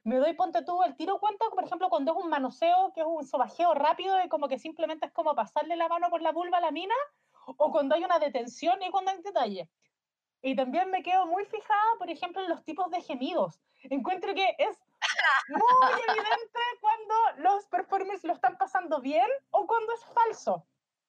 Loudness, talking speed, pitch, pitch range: -28 LUFS, 200 wpm, 355 Hz, 315-385 Hz